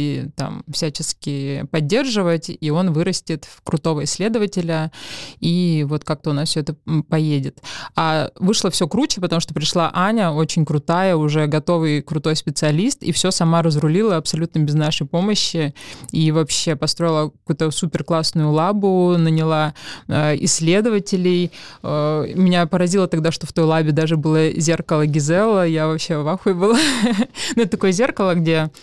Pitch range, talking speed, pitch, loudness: 155-180 Hz, 145 wpm, 165 Hz, -19 LUFS